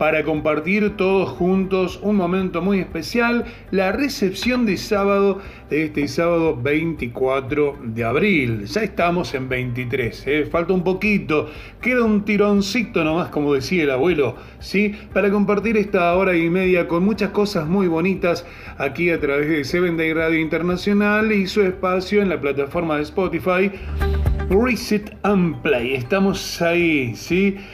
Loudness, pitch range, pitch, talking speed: -20 LUFS, 155-200 Hz, 180 Hz, 145 wpm